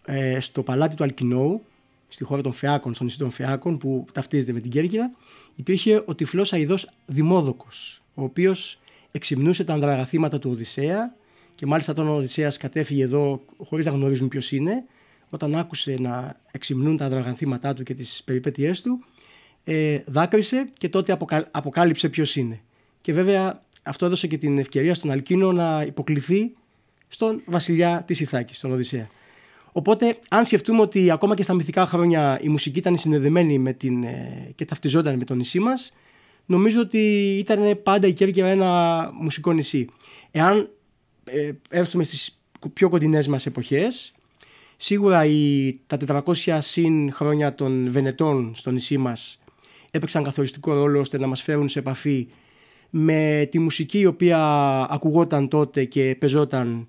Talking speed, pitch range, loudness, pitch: 150 wpm, 135-175 Hz, -22 LUFS, 150 Hz